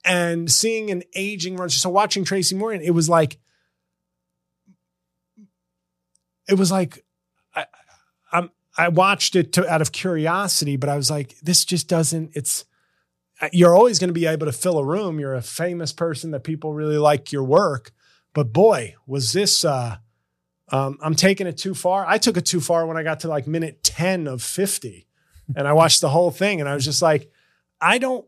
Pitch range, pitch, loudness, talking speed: 140-180 Hz, 160 Hz, -20 LUFS, 195 wpm